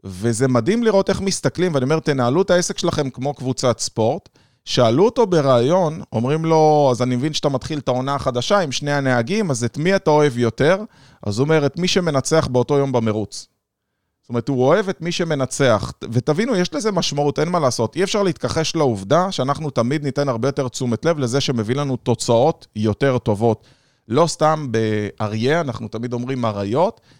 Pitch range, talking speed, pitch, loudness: 120-160 Hz, 185 wpm, 135 Hz, -19 LUFS